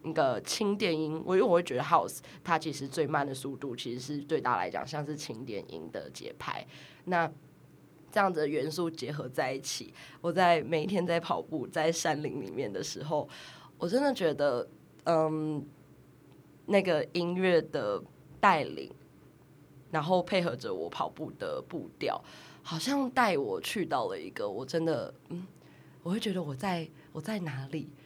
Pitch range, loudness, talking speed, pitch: 150-180 Hz, -32 LUFS, 245 characters per minute, 160 Hz